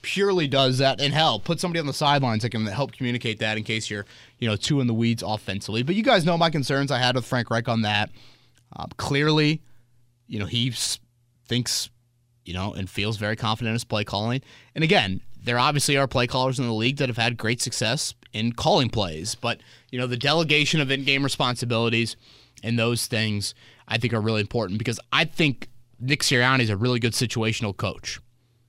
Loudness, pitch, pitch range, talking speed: -23 LUFS, 120 Hz, 110-135 Hz, 205 wpm